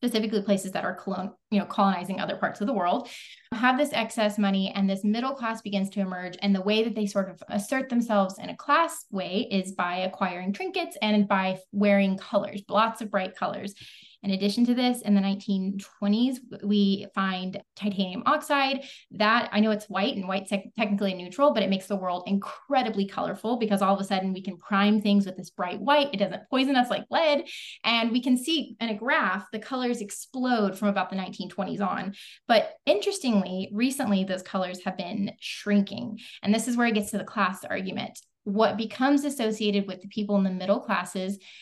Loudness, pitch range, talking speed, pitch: -27 LUFS, 195-230 Hz, 200 wpm, 205 Hz